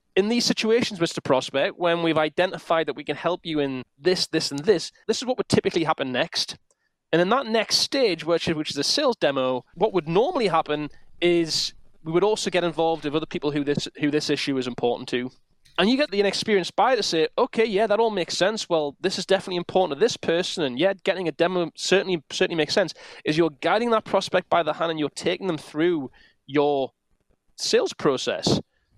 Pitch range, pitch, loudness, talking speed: 150-195 Hz, 170 Hz, -23 LUFS, 215 wpm